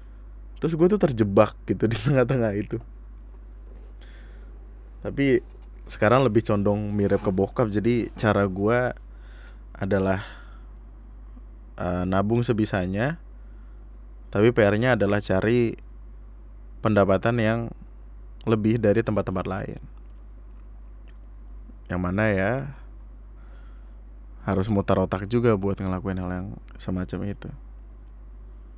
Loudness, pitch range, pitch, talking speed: -24 LUFS, 95-115 Hz, 105 Hz, 95 wpm